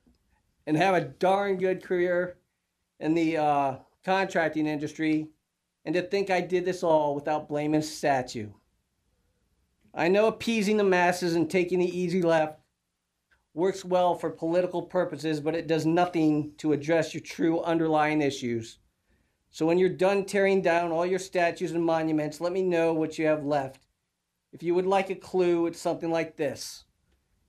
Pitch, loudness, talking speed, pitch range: 165 Hz, -27 LUFS, 165 wpm, 150-180 Hz